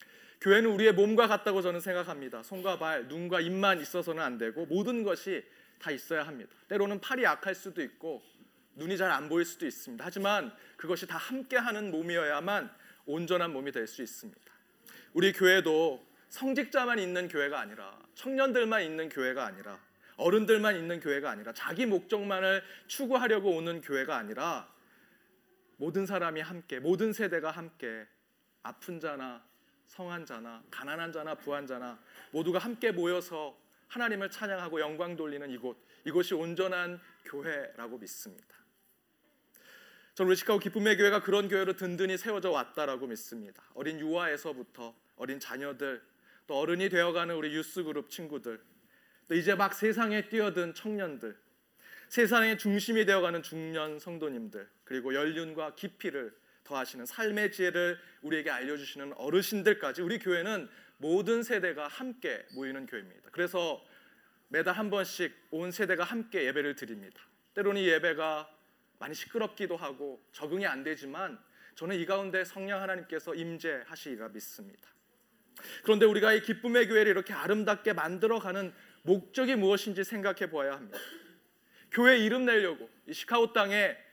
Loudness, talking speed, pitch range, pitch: -31 LUFS, 345 characters per minute, 160-215 Hz, 185 Hz